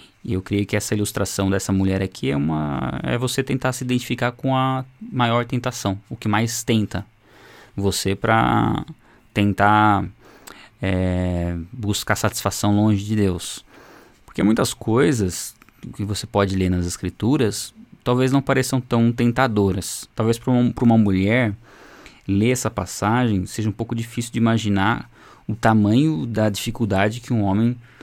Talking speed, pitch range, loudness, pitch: 145 wpm, 100-120 Hz, -21 LUFS, 110 Hz